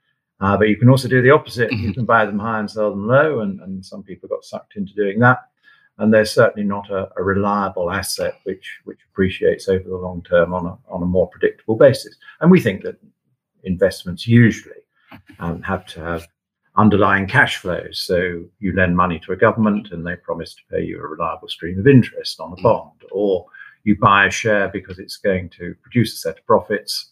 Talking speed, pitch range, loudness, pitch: 210 wpm, 95-140 Hz, -18 LUFS, 105 Hz